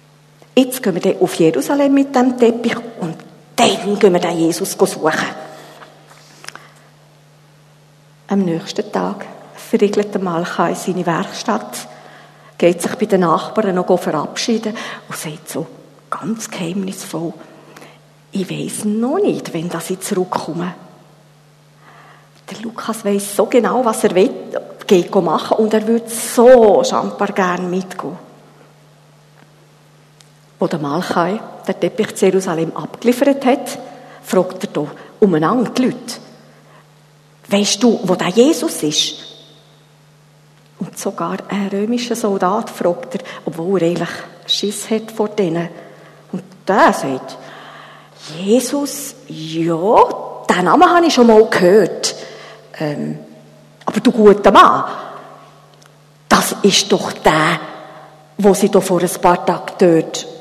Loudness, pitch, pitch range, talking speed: -16 LUFS, 185 Hz, 160-220 Hz, 125 wpm